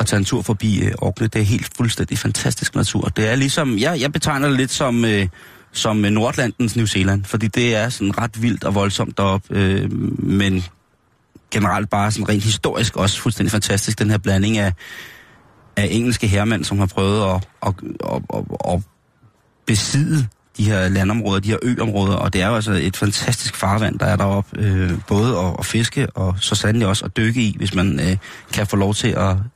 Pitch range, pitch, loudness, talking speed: 100-120 Hz, 105 Hz, -19 LUFS, 200 wpm